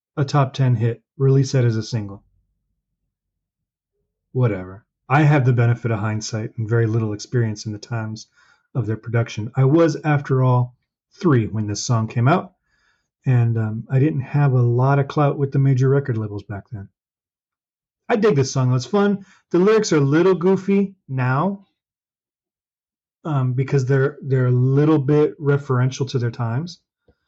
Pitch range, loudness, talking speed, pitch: 115-145 Hz, -20 LUFS, 165 wpm, 130 Hz